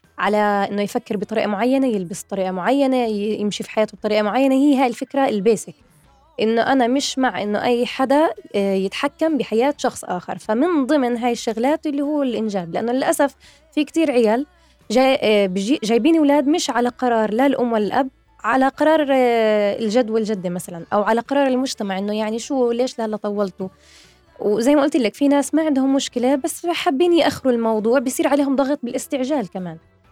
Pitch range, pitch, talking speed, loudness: 215-280 Hz, 245 Hz, 165 wpm, -19 LUFS